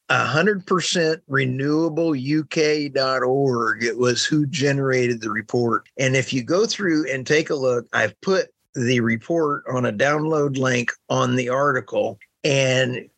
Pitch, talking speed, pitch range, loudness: 135 Hz, 135 wpm, 125-155 Hz, -21 LUFS